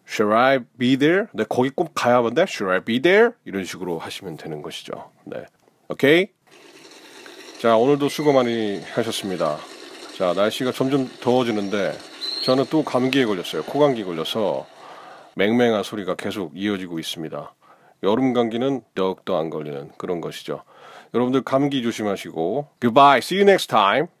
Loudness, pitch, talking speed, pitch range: -21 LUFS, 125 Hz, 395 characters per minute, 105-145 Hz